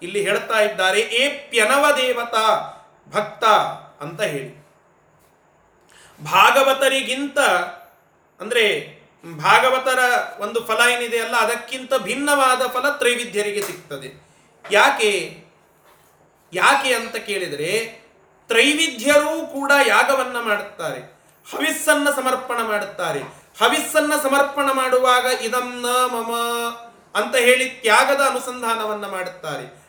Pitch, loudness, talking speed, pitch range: 250 Hz, -18 LUFS, 85 wpm, 225-275 Hz